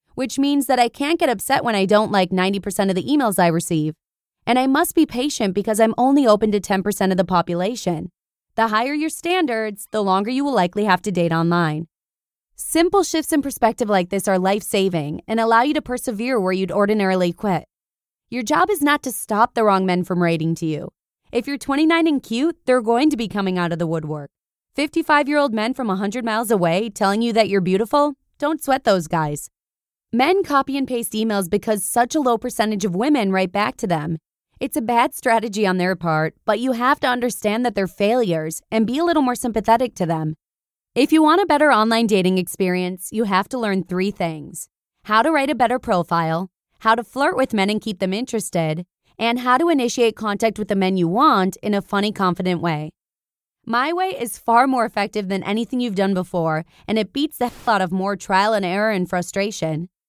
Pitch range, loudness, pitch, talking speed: 185-250 Hz, -19 LUFS, 215 Hz, 215 wpm